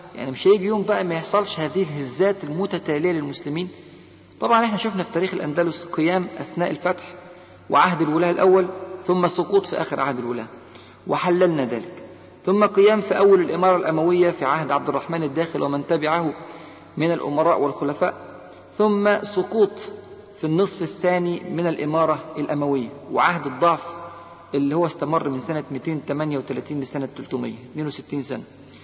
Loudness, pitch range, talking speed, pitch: -22 LUFS, 145-180 Hz, 135 wpm, 170 Hz